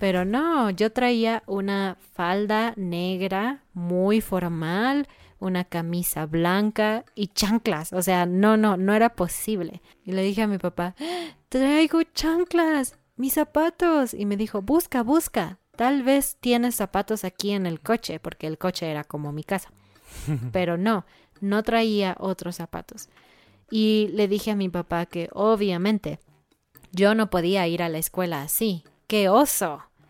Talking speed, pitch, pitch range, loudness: 150 wpm, 200 Hz, 180-230 Hz, -24 LUFS